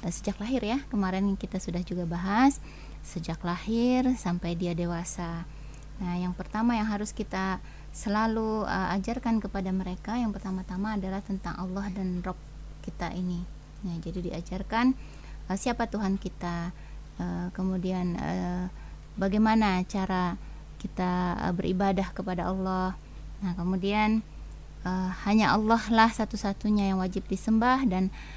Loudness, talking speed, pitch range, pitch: -29 LUFS, 130 wpm, 180-215 Hz, 190 Hz